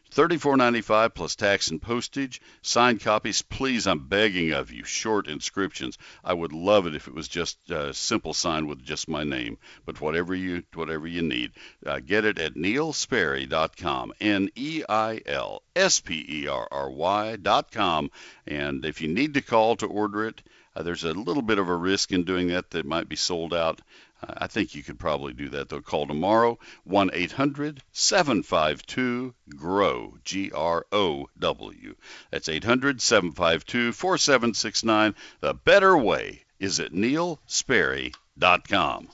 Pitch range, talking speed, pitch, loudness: 85-120 Hz, 145 wpm, 100 Hz, -25 LUFS